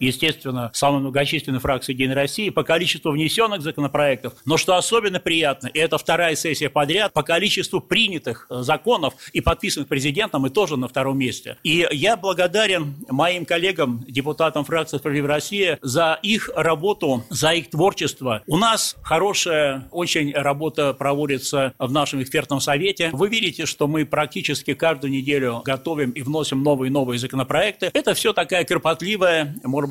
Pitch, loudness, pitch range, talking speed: 150 Hz, -20 LUFS, 140-170 Hz, 155 wpm